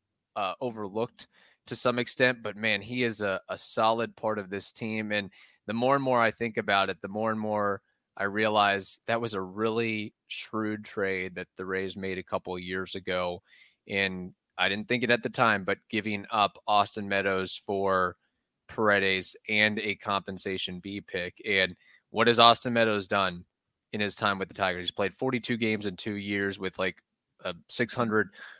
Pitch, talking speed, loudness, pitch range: 105 Hz, 185 wpm, -28 LUFS, 95-115 Hz